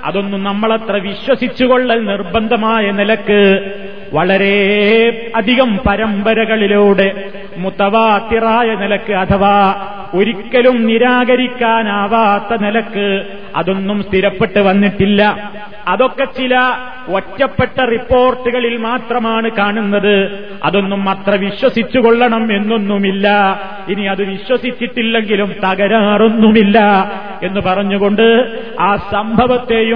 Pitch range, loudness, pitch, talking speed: 200-230 Hz, -13 LUFS, 205 Hz, 70 wpm